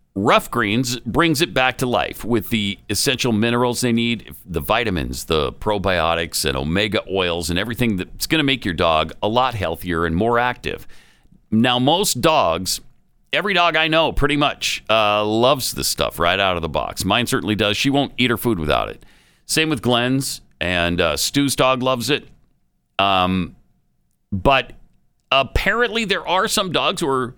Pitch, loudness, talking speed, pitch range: 120 Hz, -19 LUFS, 175 wpm, 95-135 Hz